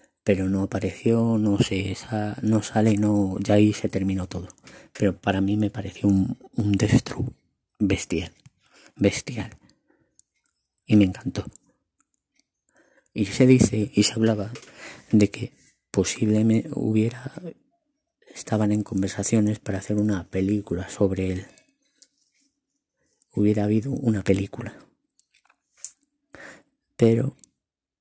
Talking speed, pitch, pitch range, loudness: 110 wpm, 105 Hz, 100-130 Hz, -23 LUFS